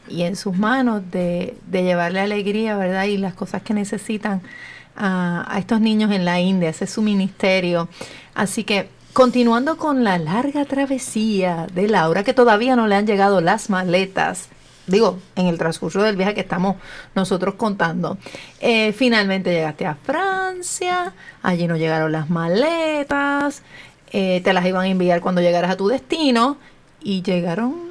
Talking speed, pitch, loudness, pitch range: 160 wpm, 195 Hz, -19 LUFS, 180-230 Hz